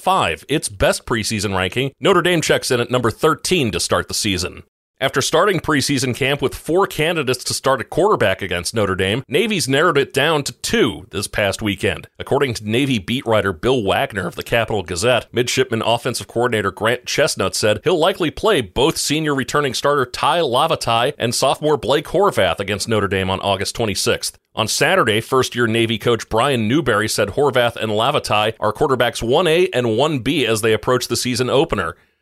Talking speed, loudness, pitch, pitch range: 180 wpm, -18 LUFS, 120 Hz, 105-135 Hz